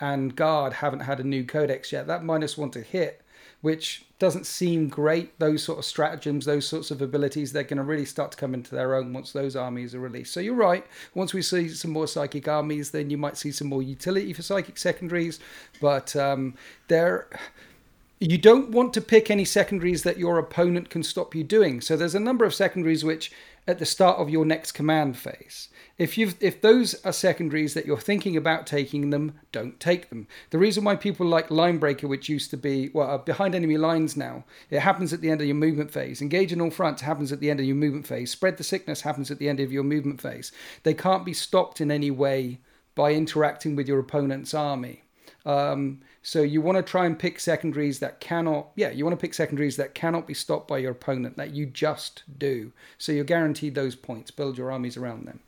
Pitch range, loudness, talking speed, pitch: 140-170 Hz, -25 LUFS, 220 wpm, 155 Hz